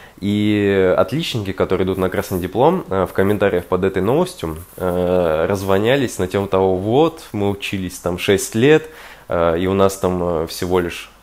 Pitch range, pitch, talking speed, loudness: 90-105 Hz, 95 Hz, 150 wpm, -18 LUFS